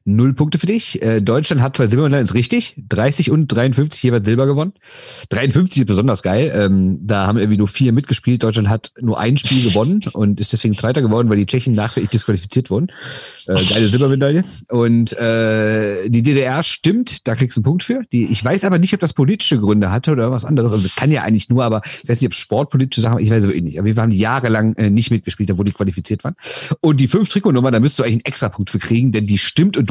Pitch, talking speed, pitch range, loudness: 120 Hz, 235 wpm, 110-140 Hz, -16 LUFS